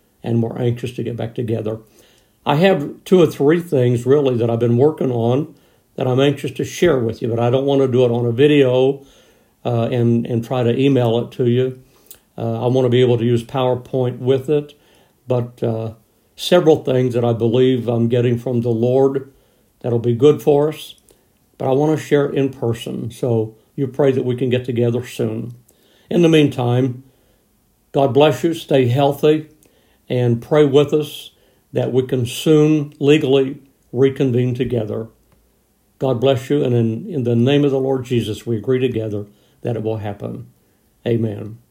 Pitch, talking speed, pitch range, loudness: 125 Hz, 185 wpm, 120-140 Hz, -17 LUFS